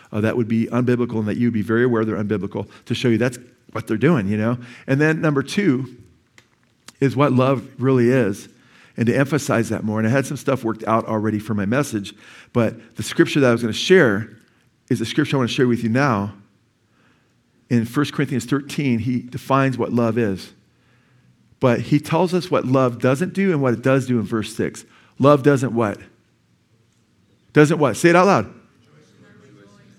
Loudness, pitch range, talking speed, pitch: -19 LUFS, 110-135 Hz, 195 wpm, 120 Hz